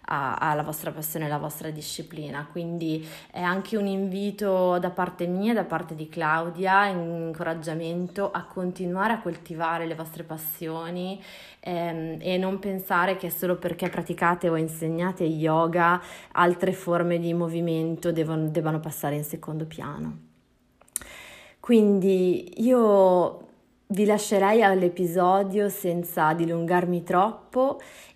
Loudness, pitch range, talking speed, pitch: -26 LUFS, 160-190 Hz, 120 wpm, 175 Hz